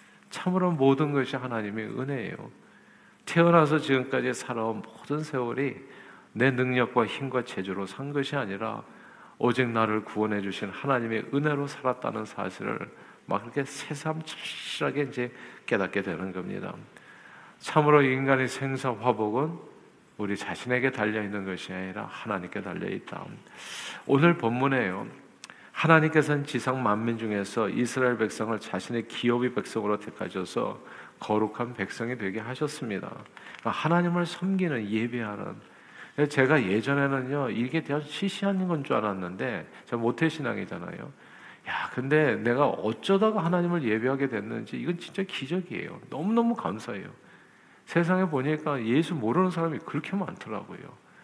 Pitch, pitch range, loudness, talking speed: 130 Hz, 110-155 Hz, -28 LUFS, 325 characters per minute